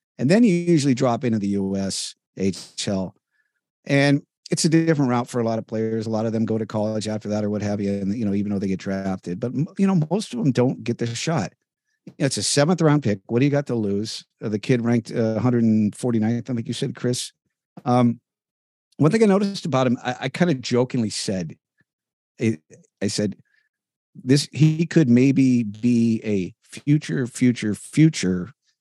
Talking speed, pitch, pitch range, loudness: 210 wpm, 120 Hz, 105-145 Hz, -22 LUFS